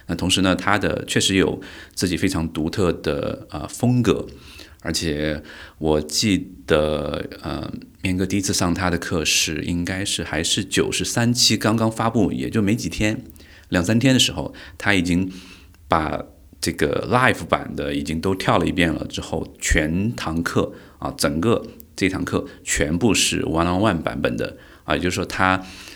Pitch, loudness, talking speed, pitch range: 90 Hz, -21 LUFS, 255 characters per minute, 80-100 Hz